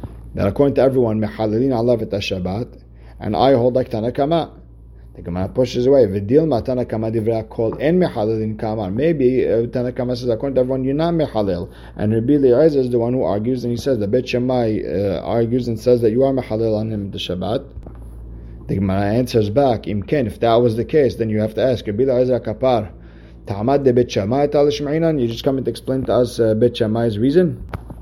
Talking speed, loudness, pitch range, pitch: 190 wpm, -18 LUFS, 105-130 Hz, 120 Hz